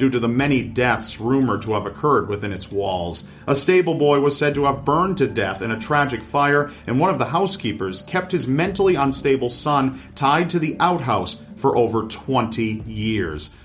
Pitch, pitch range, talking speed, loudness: 130 Hz, 110-145 Hz, 195 wpm, -20 LUFS